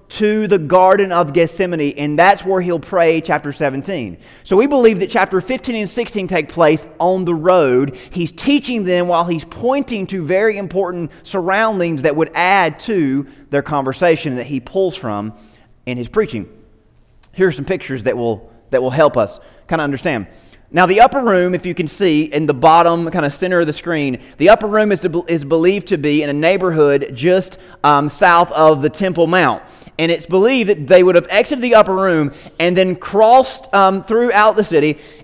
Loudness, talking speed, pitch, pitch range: -15 LUFS, 195 wpm, 175 Hz, 150-195 Hz